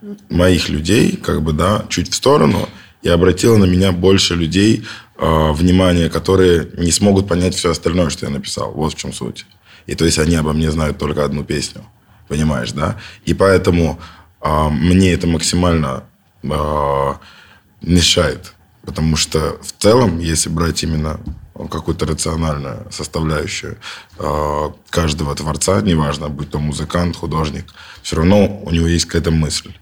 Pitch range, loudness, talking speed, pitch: 75-90 Hz, -16 LUFS, 150 wpm, 85 Hz